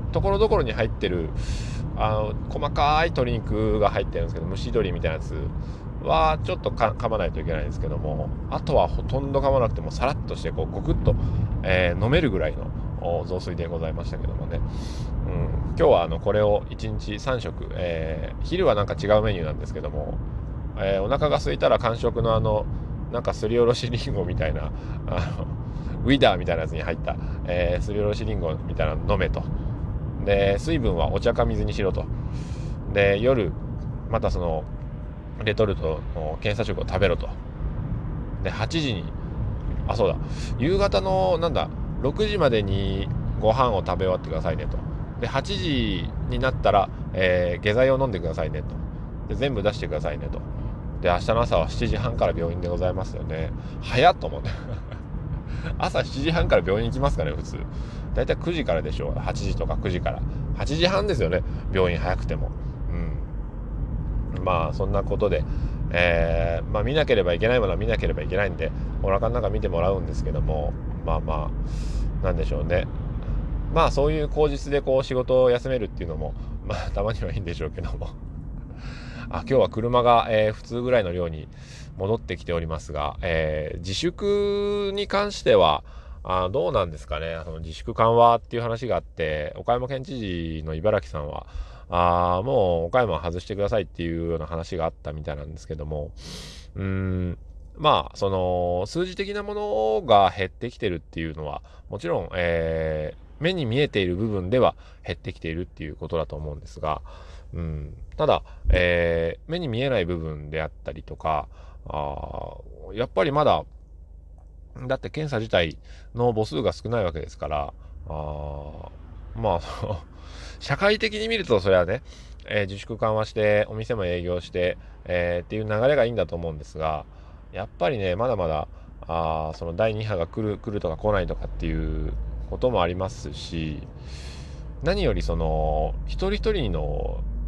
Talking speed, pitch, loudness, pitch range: 340 characters per minute, 90 Hz, -25 LUFS, 80-115 Hz